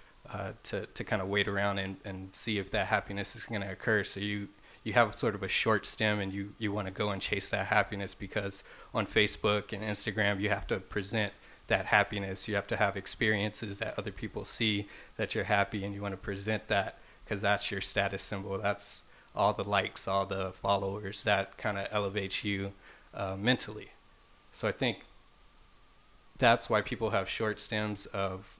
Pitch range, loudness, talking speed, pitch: 100-105 Hz, -32 LUFS, 200 wpm, 100 Hz